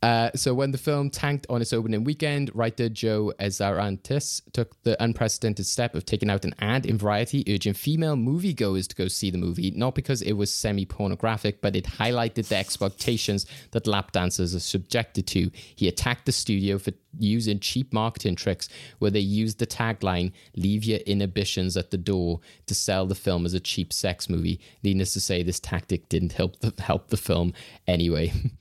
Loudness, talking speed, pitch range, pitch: -26 LUFS, 190 wpm, 95-115 Hz, 105 Hz